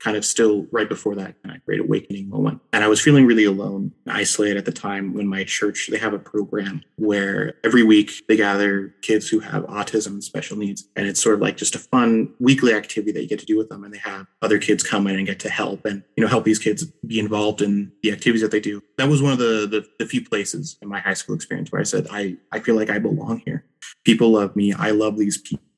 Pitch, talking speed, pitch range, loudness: 105 Hz, 265 wpm, 100-115 Hz, -20 LUFS